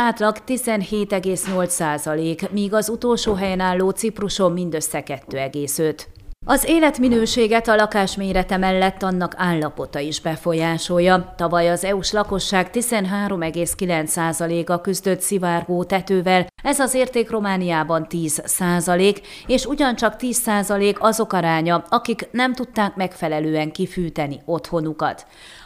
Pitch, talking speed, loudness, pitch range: 185 Hz, 110 wpm, -20 LUFS, 170-215 Hz